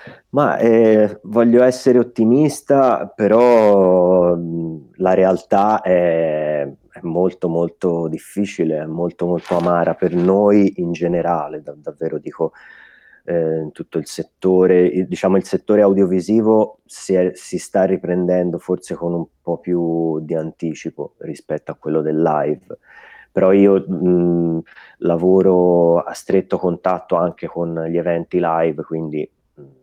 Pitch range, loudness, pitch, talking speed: 85-95 Hz, -17 LUFS, 90 Hz, 125 wpm